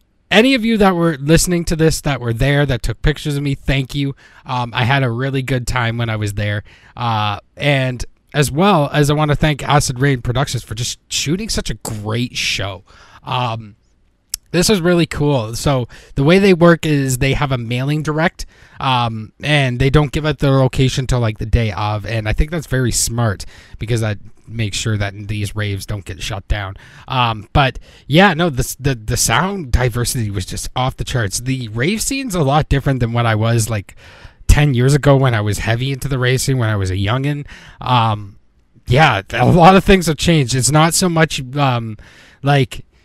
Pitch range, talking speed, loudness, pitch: 110-145 Hz, 205 wpm, -16 LUFS, 130 Hz